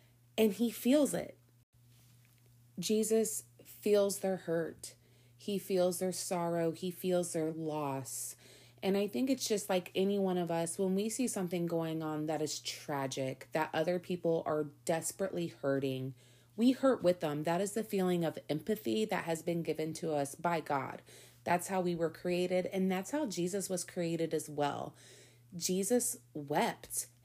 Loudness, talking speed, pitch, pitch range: -35 LUFS, 165 wpm, 170 Hz, 145-190 Hz